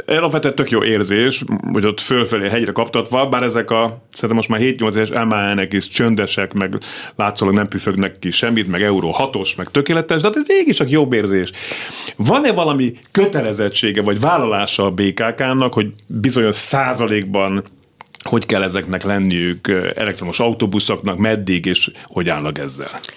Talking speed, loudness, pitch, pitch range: 150 wpm, -16 LUFS, 110 Hz, 100-120 Hz